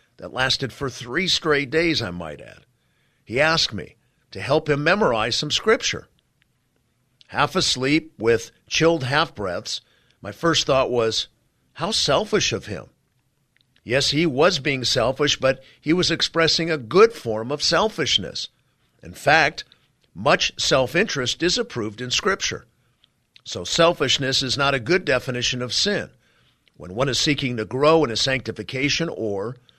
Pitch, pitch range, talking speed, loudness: 135 Hz, 120-155 Hz, 150 wpm, -21 LUFS